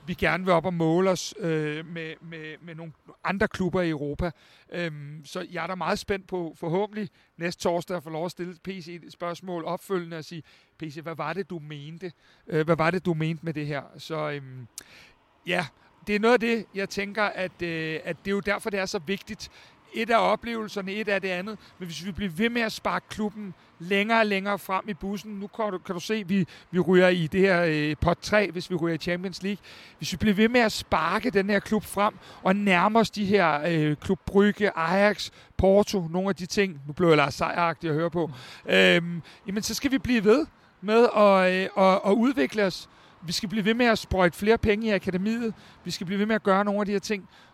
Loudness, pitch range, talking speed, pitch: -25 LUFS, 165-205 Hz, 235 wpm, 185 Hz